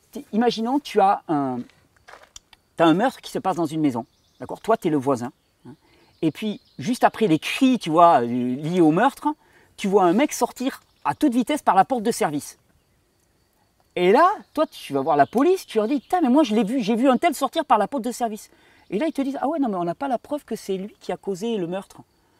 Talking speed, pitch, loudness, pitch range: 245 wpm, 230 Hz, -22 LUFS, 175-270 Hz